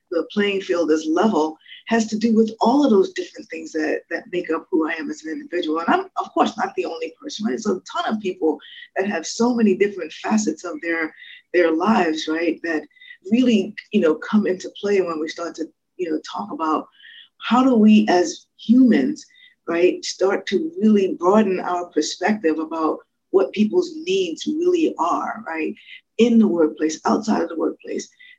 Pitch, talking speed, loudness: 215 Hz, 190 wpm, -20 LUFS